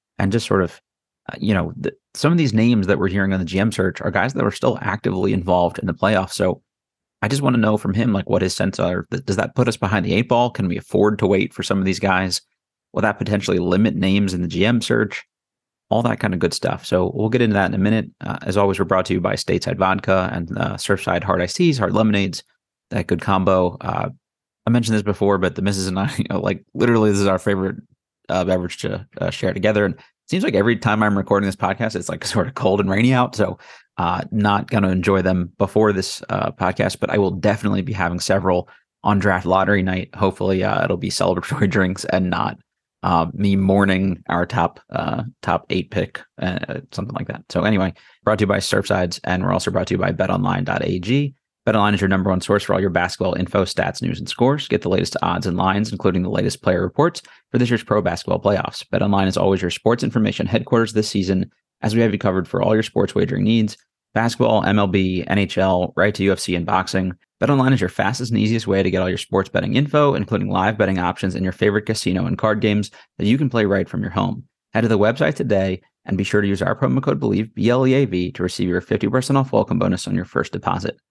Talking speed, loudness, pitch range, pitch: 245 wpm, -20 LUFS, 95-110 Hz, 100 Hz